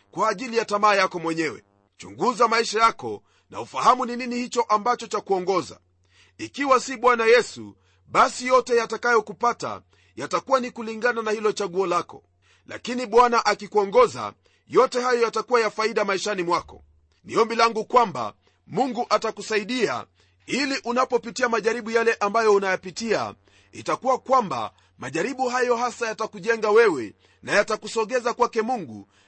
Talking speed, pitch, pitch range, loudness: 125 wpm, 230 Hz, 205-245 Hz, -23 LUFS